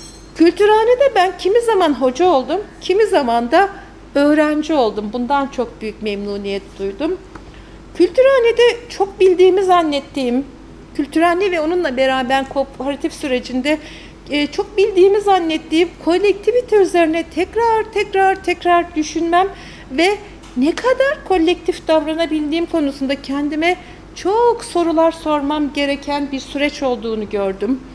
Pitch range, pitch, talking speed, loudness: 275-370 Hz, 325 Hz, 105 wpm, -16 LUFS